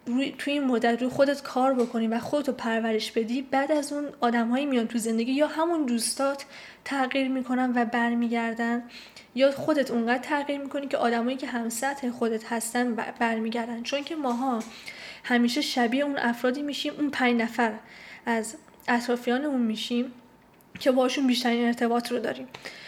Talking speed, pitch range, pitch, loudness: 155 wpm, 235-275 Hz, 245 Hz, -27 LUFS